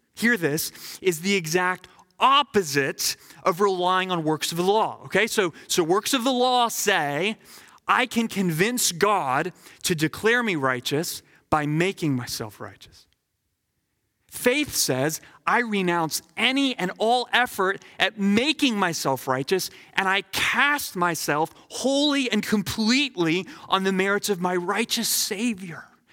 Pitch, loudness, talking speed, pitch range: 190 Hz, -23 LUFS, 135 wpm, 170-235 Hz